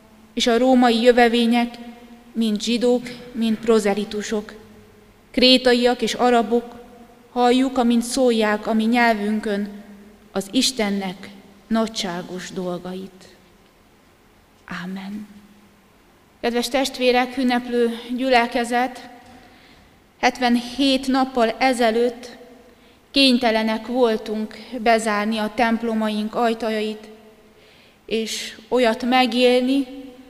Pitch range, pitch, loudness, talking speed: 215-245 Hz, 235 Hz, -20 LUFS, 75 wpm